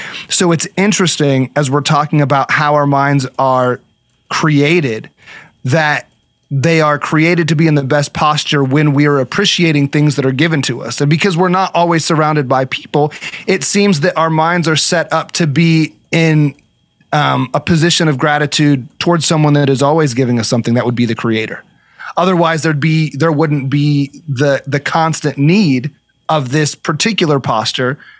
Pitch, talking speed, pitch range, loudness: 150 Hz, 175 wpm, 140-165 Hz, -12 LUFS